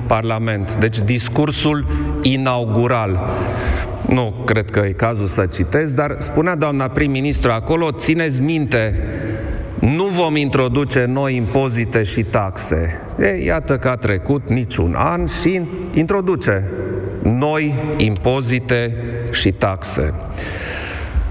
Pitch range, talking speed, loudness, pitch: 100-145 Hz, 105 wpm, -18 LUFS, 120 Hz